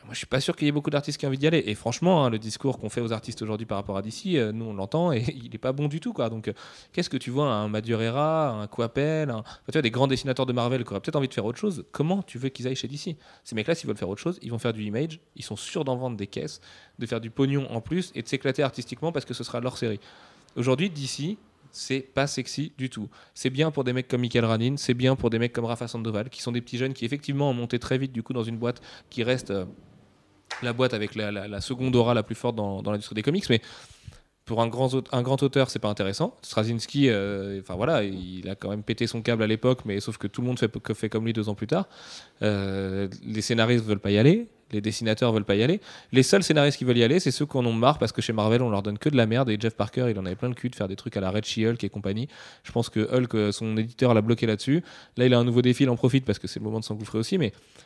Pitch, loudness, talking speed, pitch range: 120 Hz, -26 LUFS, 300 wpm, 110-135 Hz